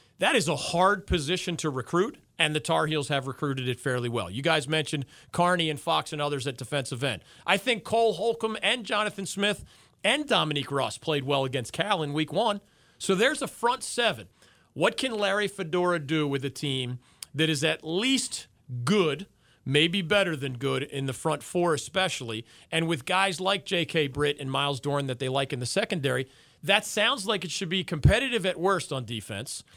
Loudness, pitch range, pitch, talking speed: -27 LUFS, 135-190 Hz, 155 Hz, 195 wpm